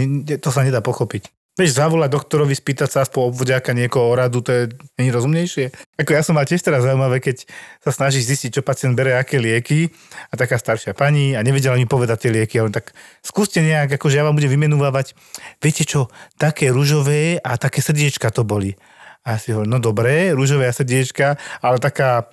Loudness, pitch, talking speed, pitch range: -18 LUFS, 135 Hz, 195 wpm, 125-145 Hz